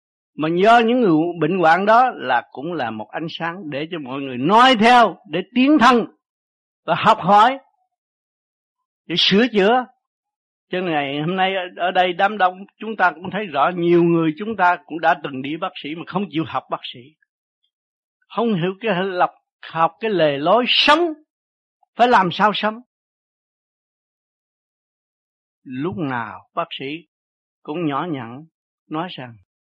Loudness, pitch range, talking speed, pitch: -18 LUFS, 160-235 Hz, 160 wpm, 185 Hz